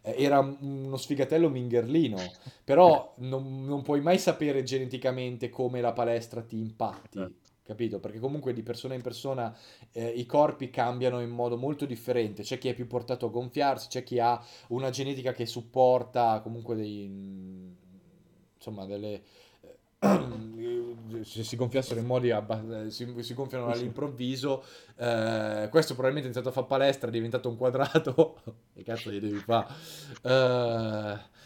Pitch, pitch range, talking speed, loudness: 120 Hz, 115-130 Hz, 150 wpm, -29 LUFS